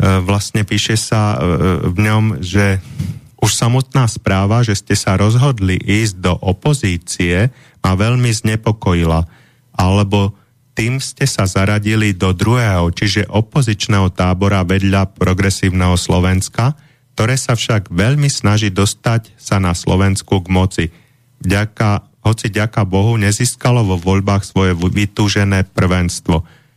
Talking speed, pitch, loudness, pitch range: 120 wpm, 105 Hz, -15 LUFS, 95-115 Hz